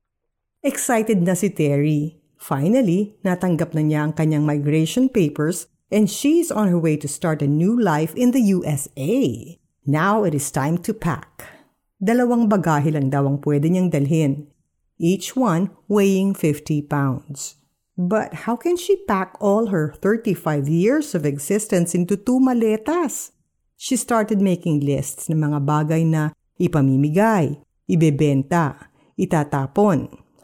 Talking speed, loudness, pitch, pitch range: 135 wpm, -20 LUFS, 170 Hz, 150-205 Hz